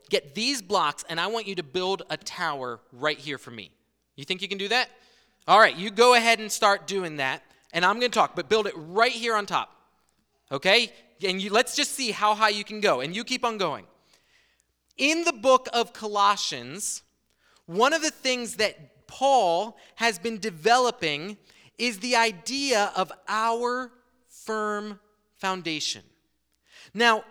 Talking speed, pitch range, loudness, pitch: 175 wpm, 185-240 Hz, -24 LUFS, 215 Hz